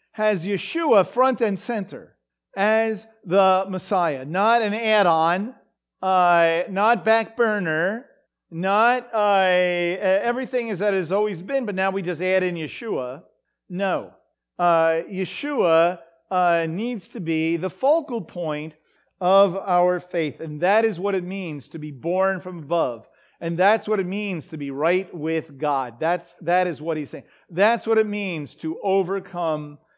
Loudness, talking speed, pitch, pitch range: -22 LUFS, 155 wpm, 185 Hz, 170-210 Hz